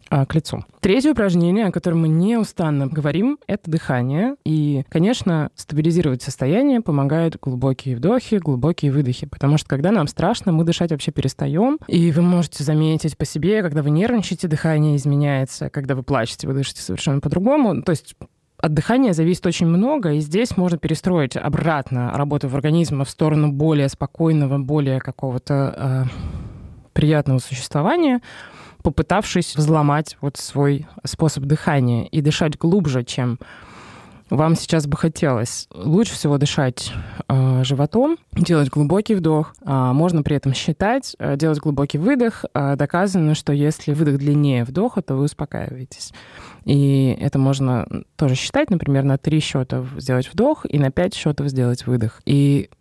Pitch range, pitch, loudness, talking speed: 135-170 Hz, 150 Hz, -19 LUFS, 145 wpm